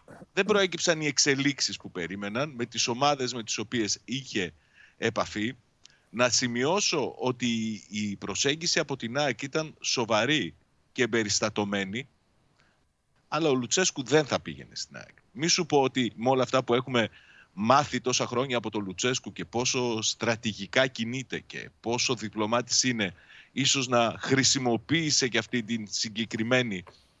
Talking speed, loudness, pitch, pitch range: 140 wpm, -27 LUFS, 120 Hz, 110-135 Hz